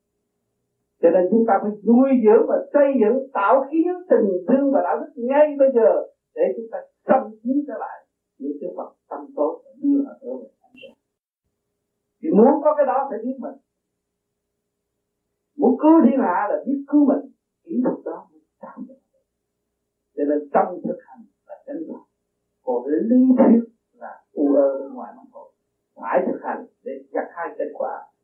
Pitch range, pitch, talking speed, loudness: 225-285 Hz, 260 Hz, 185 wpm, -19 LUFS